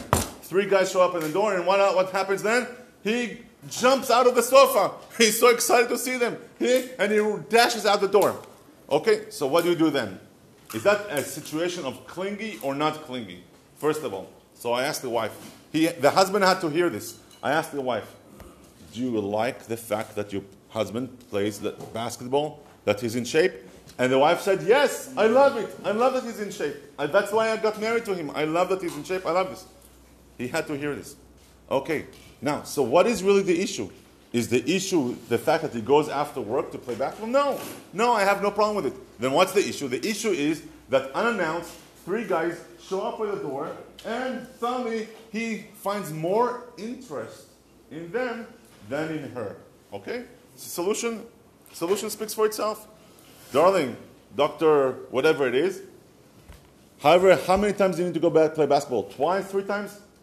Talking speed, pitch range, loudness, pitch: 200 wpm, 145-225 Hz, -24 LUFS, 190 Hz